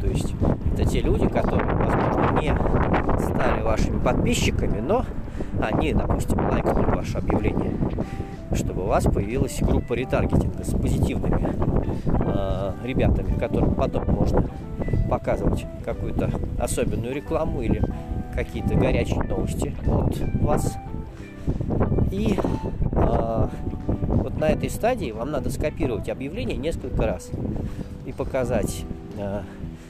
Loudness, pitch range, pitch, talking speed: -25 LUFS, 80-105 Hz, 95 Hz, 110 wpm